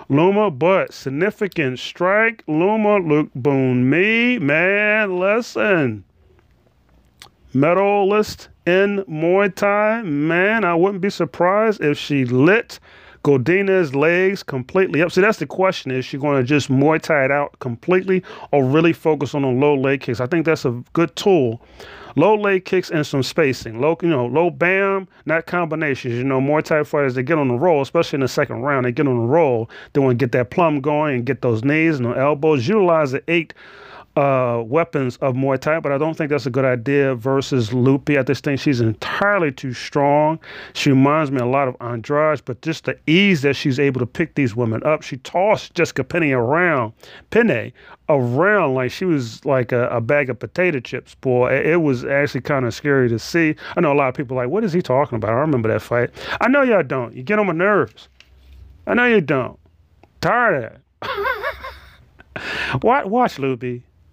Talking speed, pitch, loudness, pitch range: 195 wpm, 145 Hz, -18 LUFS, 130-175 Hz